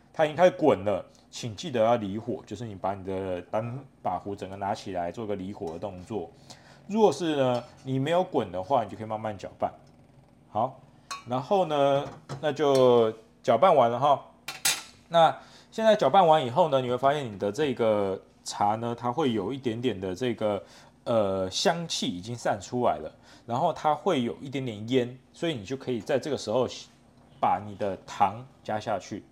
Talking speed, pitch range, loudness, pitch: 260 characters per minute, 105-140 Hz, -27 LUFS, 120 Hz